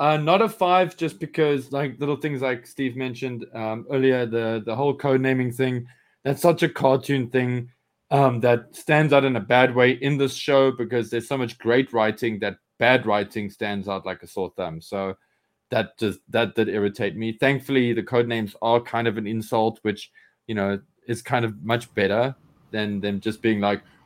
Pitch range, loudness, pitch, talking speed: 110-135 Hz, -23 LUFS, 120 Hz, 200 wpm